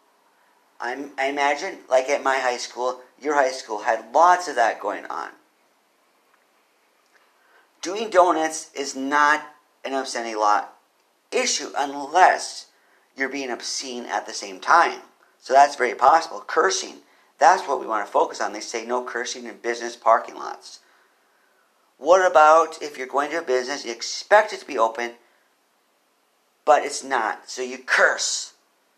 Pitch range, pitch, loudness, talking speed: 120-150 Hz, 135 Hz, -21 LUFS, 150 wpm